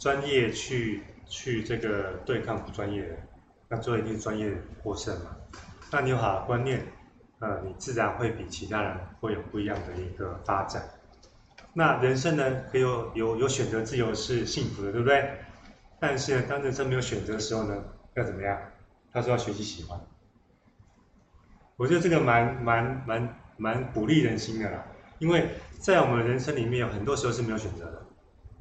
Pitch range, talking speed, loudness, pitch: 100-125 Hz, 265 characters per minute, -29 LUFS, 110 Hz